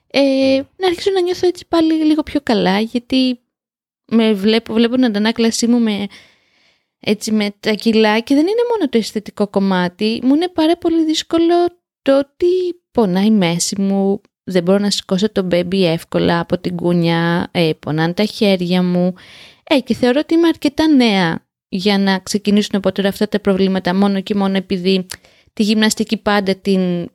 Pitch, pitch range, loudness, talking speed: 215 Hz, 195-275 Hz, -16 LUFS, 170 wpm